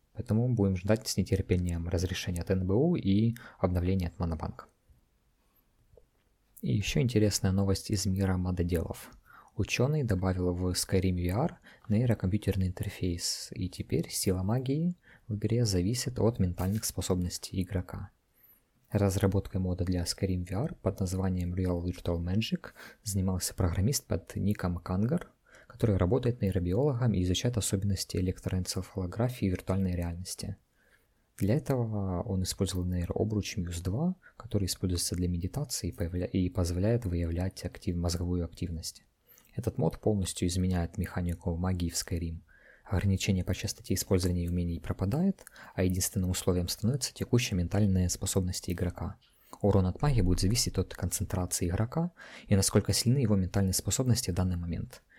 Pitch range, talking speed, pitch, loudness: 90-105 Hz, 130 wpm, 95 Hz, -31 LUFS